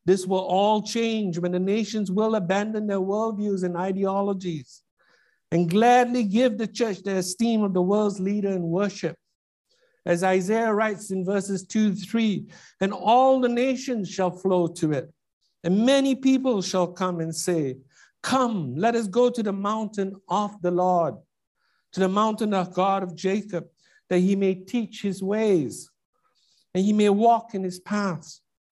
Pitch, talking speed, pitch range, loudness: 195 Hz, 165 wpm, 180-220 Hz, -24 LUFS